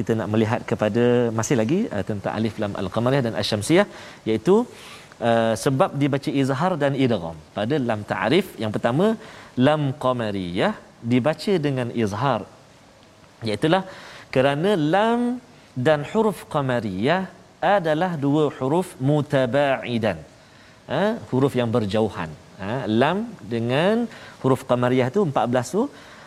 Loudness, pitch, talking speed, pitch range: -22 LUFS, 130 Hz, 120 wpm, 110-155 Hz